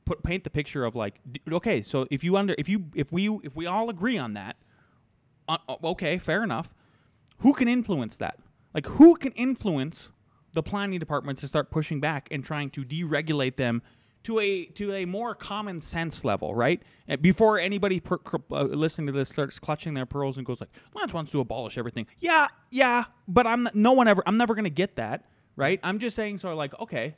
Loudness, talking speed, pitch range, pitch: -26 LUFS, 210 wpm, 140-205 Hz, 165 Hz